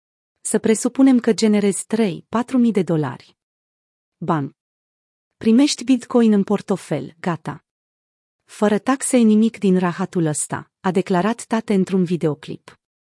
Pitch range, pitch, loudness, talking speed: 155-225 Hz, 195 Hz, -19 LUFS, 115 wpm